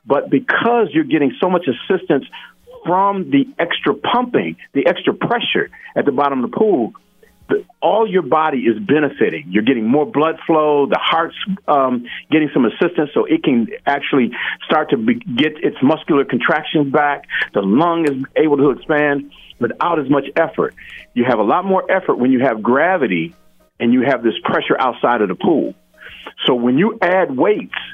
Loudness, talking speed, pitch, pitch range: -16 LUFS, 180 wpm, 160 Hz, 140-200 Hz